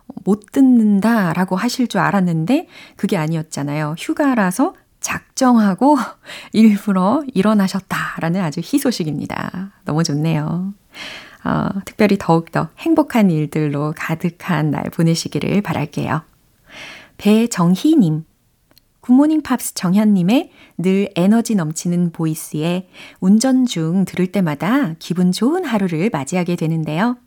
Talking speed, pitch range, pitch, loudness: 275 characters per minute, 165-230 Hz, 190 Hz, -17 LUFS